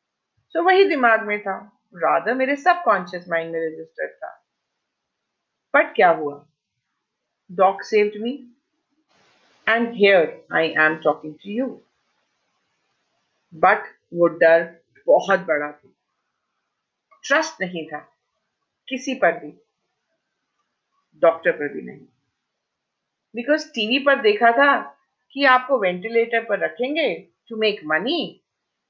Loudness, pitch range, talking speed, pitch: -20 LUFS, 165-260 Hz, 110 wpm, 210 Hz